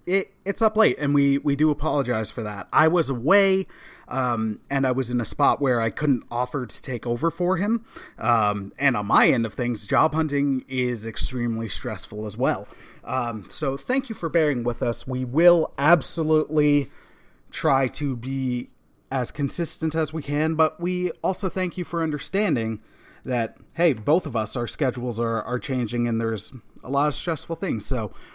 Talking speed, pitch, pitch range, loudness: 185 wpm, 135 Hz, 120-160 Hz, -24 LUFS